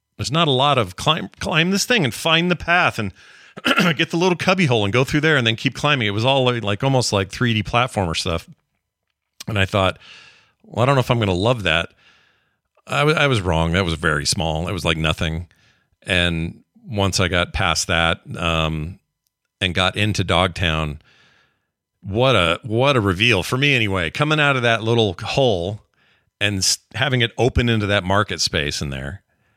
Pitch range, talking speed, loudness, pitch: 90-130 Hz, 195 wpm, -19 LUFS, 105 Hz